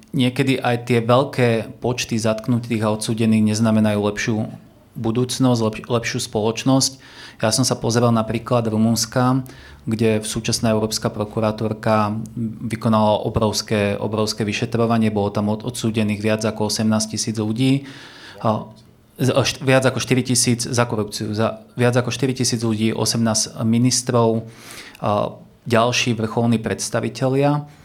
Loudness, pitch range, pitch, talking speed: -20 LUFS, 110-125 Hz, 115 Hz, 140 wpm